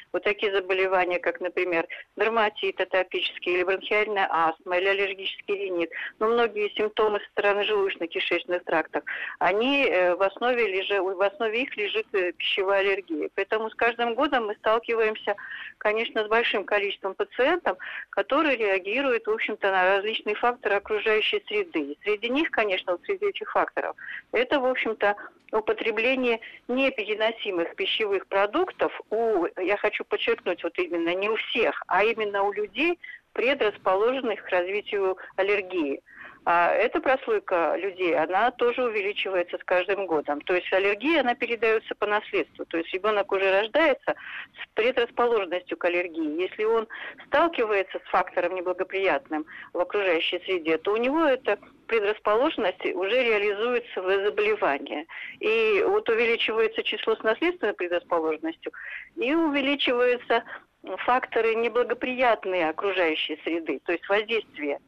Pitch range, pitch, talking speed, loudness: 190-280 Hz, 215 Hz, 130 wpm, -25 LUFS